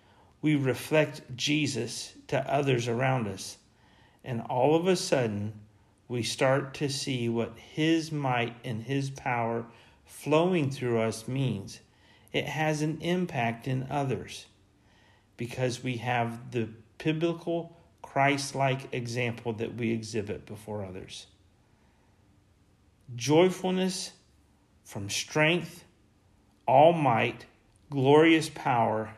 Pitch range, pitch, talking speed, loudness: 105-140 Hz, 120 Hz, 105 wpm, -28 LUFS